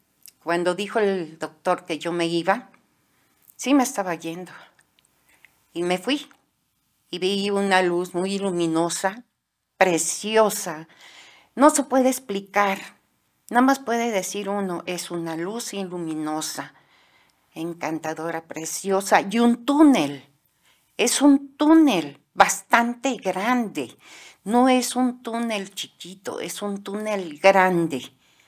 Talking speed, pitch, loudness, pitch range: 115 wpm, 195 Hz, -22 LUFS, 170-235 Hz